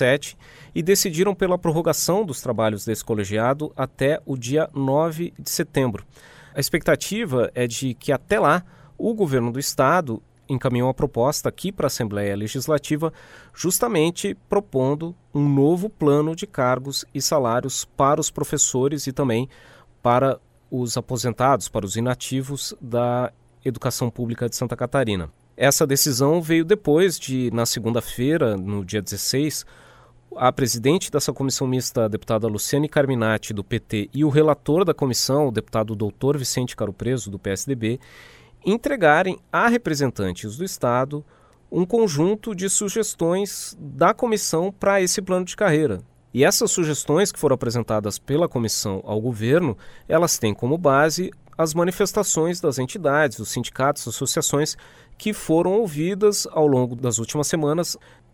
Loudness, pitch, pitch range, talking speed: -22 LUFS, 140 Hz, 120-165 Hz, 140 wpm